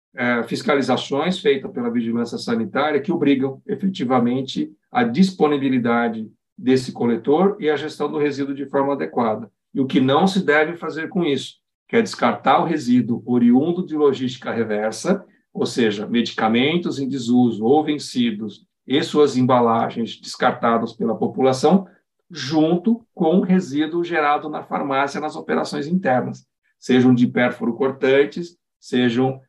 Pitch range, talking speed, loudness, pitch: 125-180 Hz, 135 wpm, -20 LUFS, 145 Hz